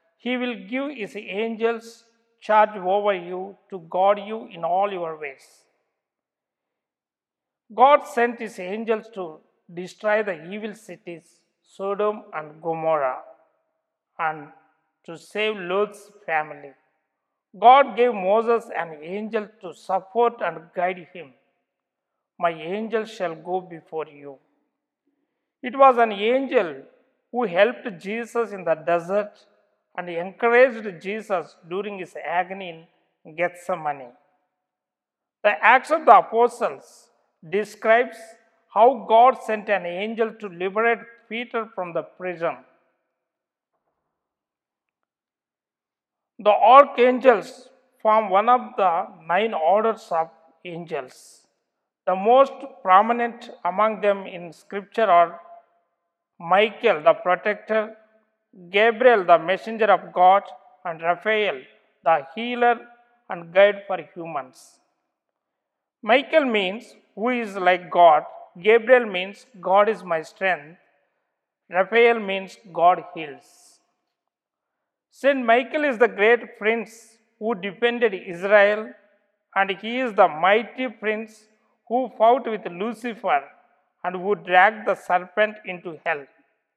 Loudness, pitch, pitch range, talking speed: -21 LUFS, 205 Hz, 175-230 Hz, 110 wpm